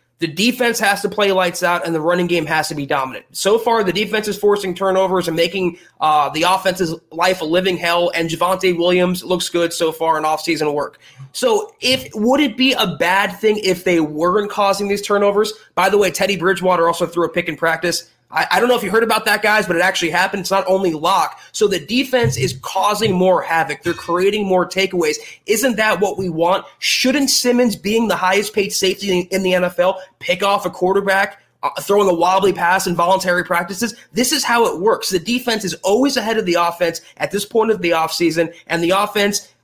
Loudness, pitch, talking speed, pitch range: -17 LUFS, 190 Hz, 220 wpm, 170-210 Hz